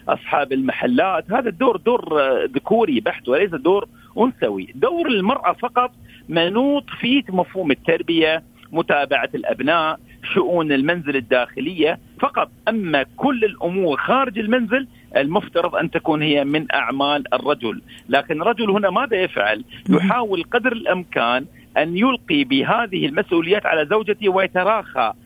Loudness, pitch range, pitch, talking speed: -19 LUFS, 160-250 Hz, 190 Hz, 120 wpm